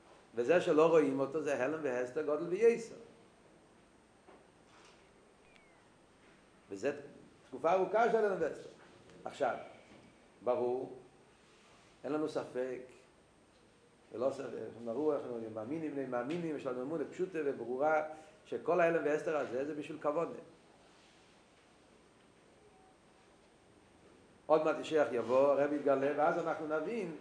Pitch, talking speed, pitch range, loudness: 155 Hz, 115 wpm, 135-160 Hz, -35 LUFS